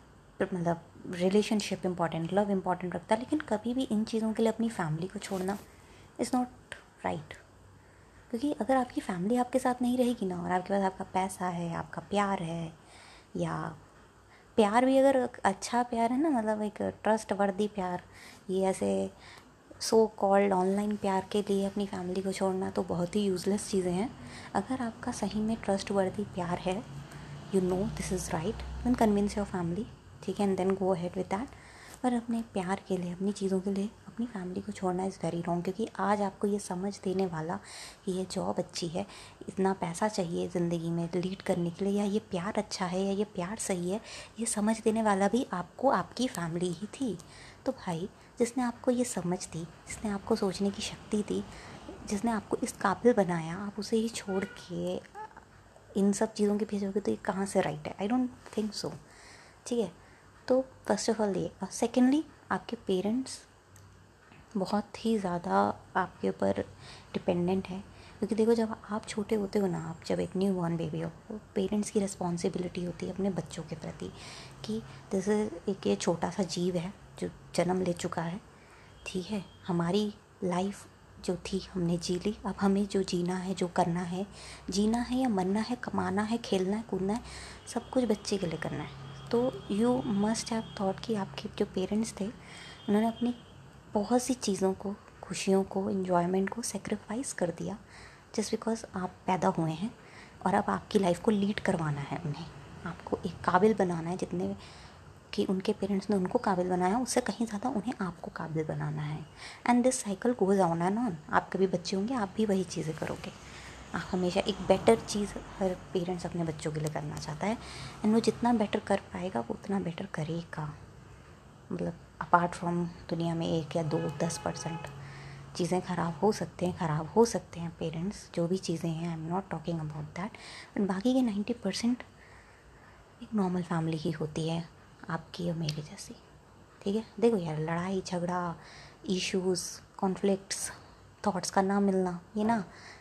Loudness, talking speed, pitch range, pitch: -32 LUFS, 185 wpm, 175-215 Hz, 195 Hz